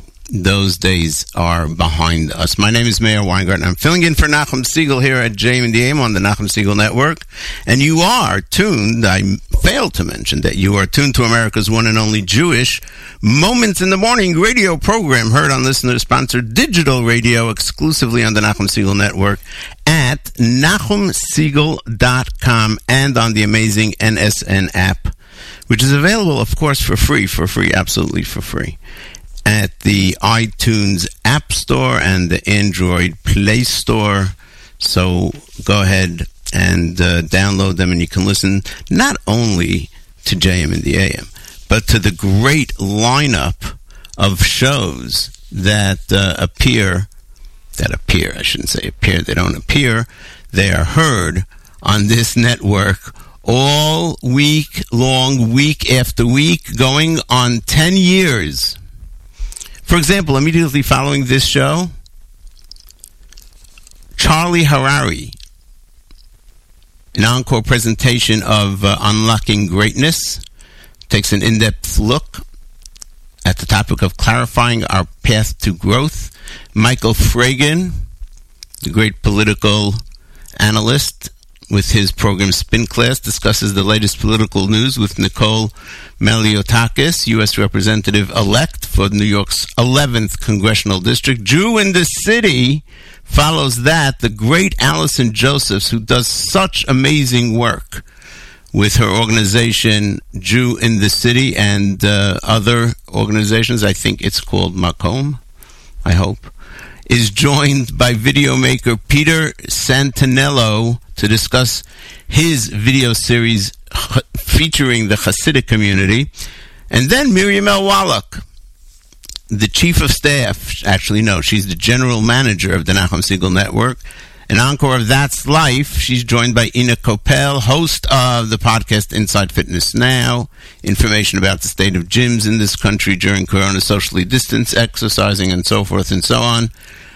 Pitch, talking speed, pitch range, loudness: 110 Hz, 135 wpm, 95-130 Hz, -13 LUFS